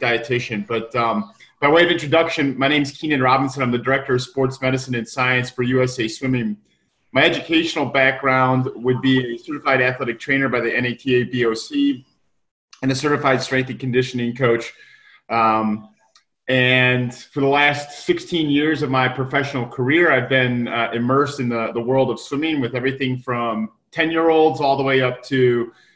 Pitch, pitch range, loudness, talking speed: 130 Hz, 125-145 Hz, -19 LUFS, 175 wpm